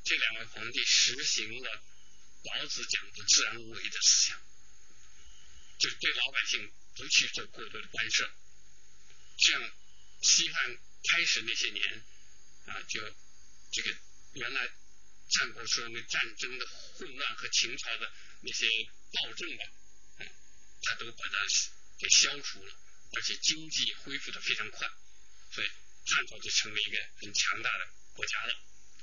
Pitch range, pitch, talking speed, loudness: 70-115 Hz, 85 Hz, 210 characters per minute, -30 LUFS